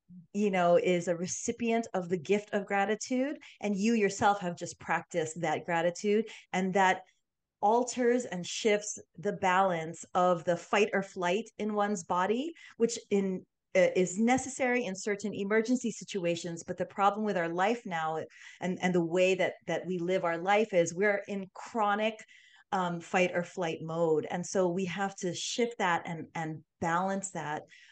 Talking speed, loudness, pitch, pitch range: 170 wpm, -31 LUFS, 190 Hz, 175-210 Hz